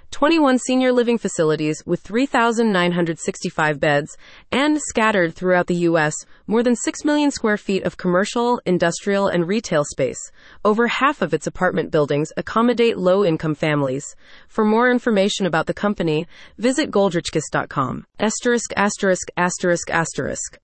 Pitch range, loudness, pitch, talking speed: 170-235 Hz, -19 LUFS, 190 Hz, 130 wpm